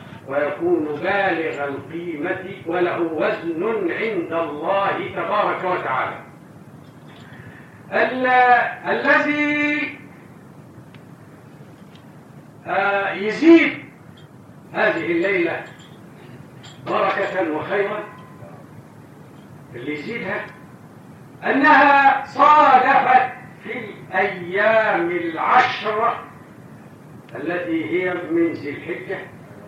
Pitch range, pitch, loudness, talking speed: 170-280 Hz, 195 Hz, -19 LUFS, 60 wpm